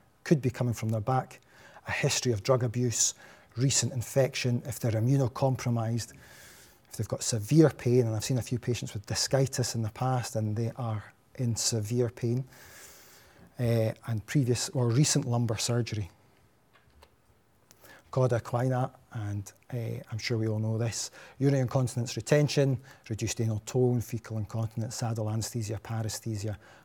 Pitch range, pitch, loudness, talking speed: 110-130 Hz, 120 Hz, -30 LUFS, 150 wpm